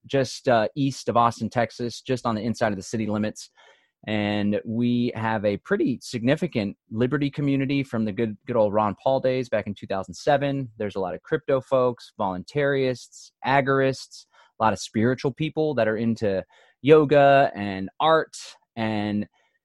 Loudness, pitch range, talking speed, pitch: -24 LUFS, 105-140 Hz, 160 wpm, 120 Hz